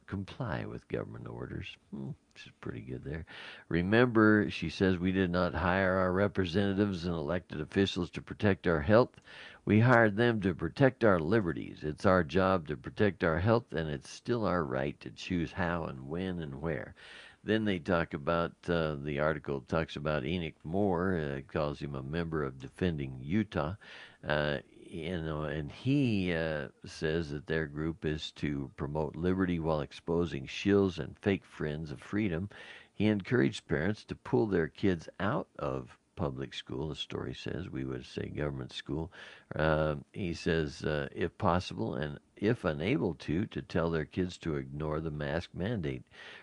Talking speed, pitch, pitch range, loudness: 170 wpm, 85 Hz, 75-95 Hz, -32 LUFS